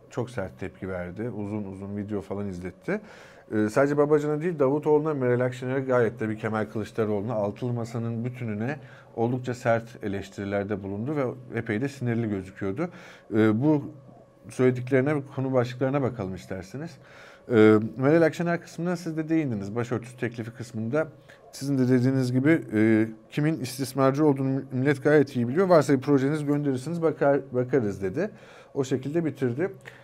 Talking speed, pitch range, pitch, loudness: 145 wpm, 110-140 Hz, 125 Hz, -26 LUFS